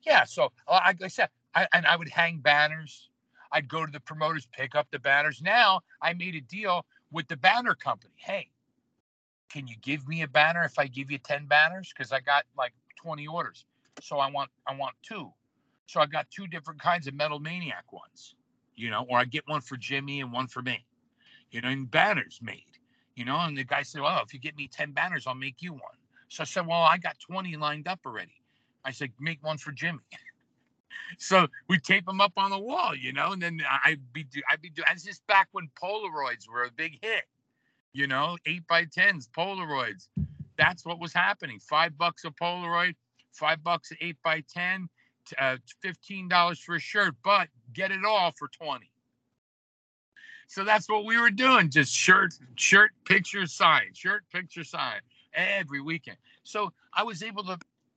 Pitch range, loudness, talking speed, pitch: 140-180 Hz, -27 LUFS, 200 wpm, 160 Hz